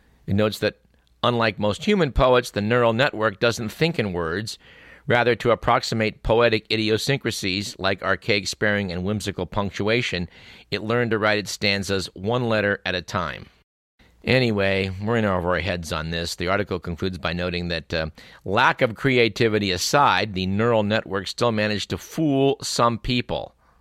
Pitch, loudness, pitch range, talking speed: 105 Hz, -22 LUFS, 95-115 Hz, 160 wpm